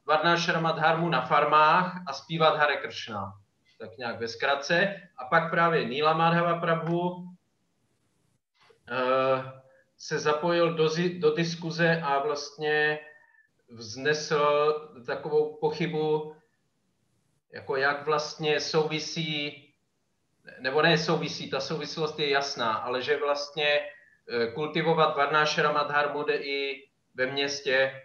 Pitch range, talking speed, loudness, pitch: 140-165 Hz, 105 wpm, -26 LUFS, 150 Hz